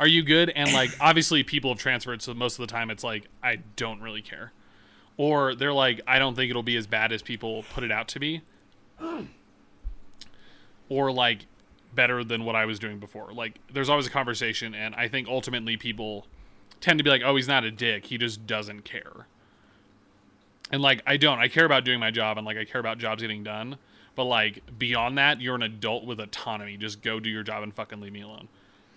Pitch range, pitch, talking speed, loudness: 110-130 Hz, 115 Hz, 220 wpm, -25 LUFS